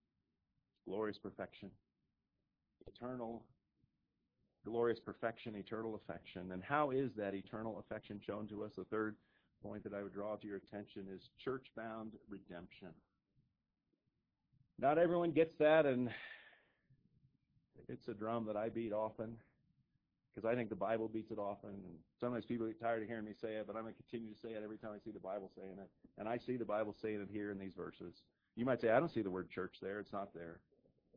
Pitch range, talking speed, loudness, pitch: 100-115 Hz, 190 wpm, -42 LUFS, 110 Hz